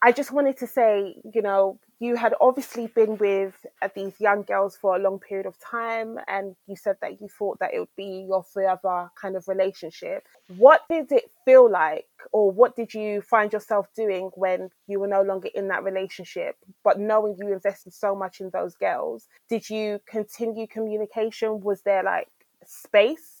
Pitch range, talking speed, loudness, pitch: 195-225 Hz, 190 wpm, -24 LUFS, 205 Hz